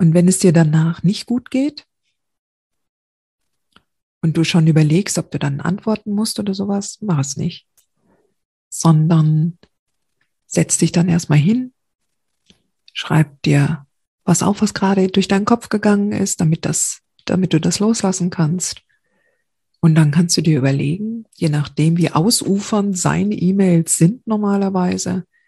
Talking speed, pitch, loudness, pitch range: 140 wpm, 180 Hz, -17 LUFS, 165-205 Hz